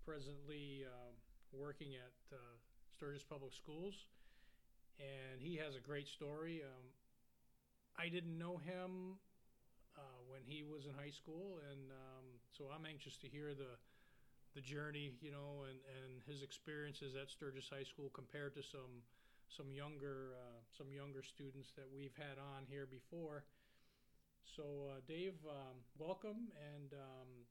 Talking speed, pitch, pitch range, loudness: 150 wpm, 140 Hz, 130-150 Hz, -54 LUFS